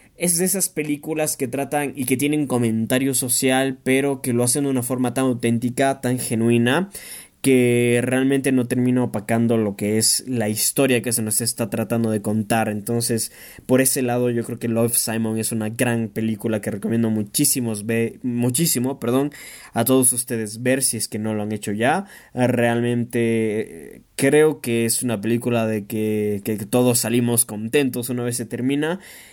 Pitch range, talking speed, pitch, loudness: 115-130 Hz, 175 wpm, 120 Hz, -20 LUFS